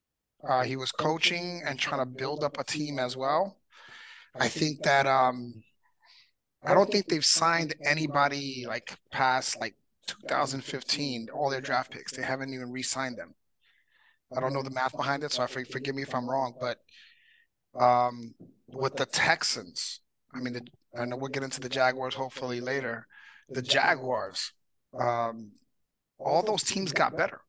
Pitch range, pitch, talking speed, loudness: 125-150 Hz, 135 Hz, 160 wpm, -29 LUFS